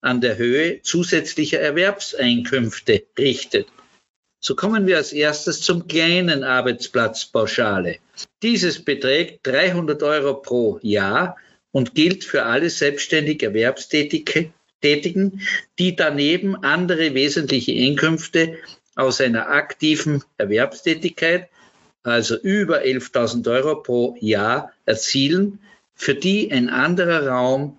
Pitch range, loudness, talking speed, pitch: 130-180 Hz, -19 LUFS, 100 wpm, 150 Hz